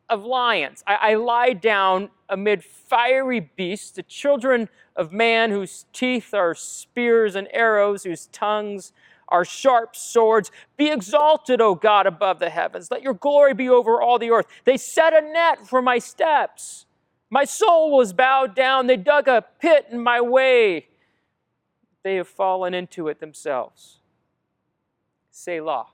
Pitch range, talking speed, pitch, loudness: 195-260 Hz, 150 wpm, 230 Hz, -20 LUFS